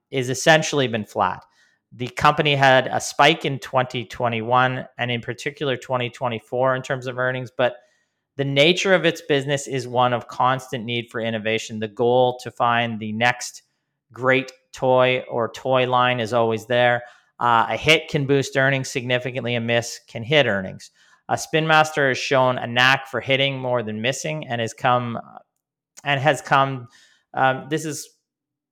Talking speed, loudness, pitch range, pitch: 165 wpm, -20 LUFS, 120-140 Hz, 130 Hz